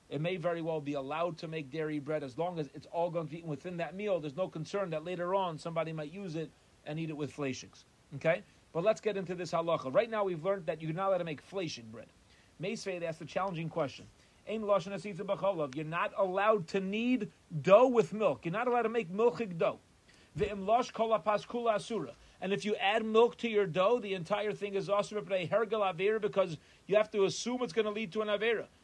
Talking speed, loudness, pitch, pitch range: 210 wpm, -33 LUFS, 190 Hz, 160-210 Hz